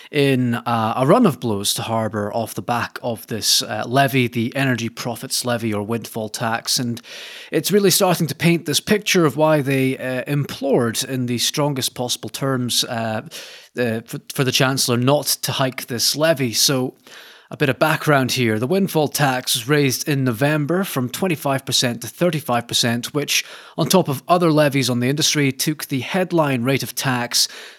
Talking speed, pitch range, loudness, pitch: 180 wpm, 120-150 Hz, -19 LUFS, 130 Hz